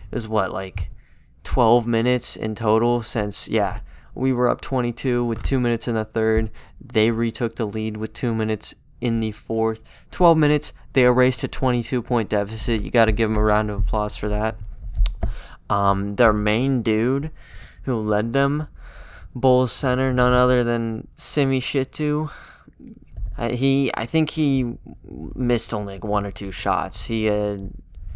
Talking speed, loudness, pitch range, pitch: 165 wpm, -21 LUFS, 105-125 Hz, 115 Hz